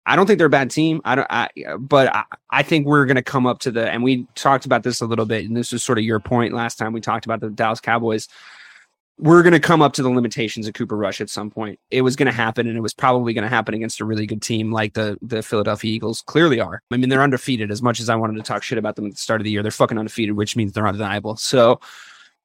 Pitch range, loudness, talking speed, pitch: 110-130 Hz, -19 LUFS, 295 wpm, 115 Hz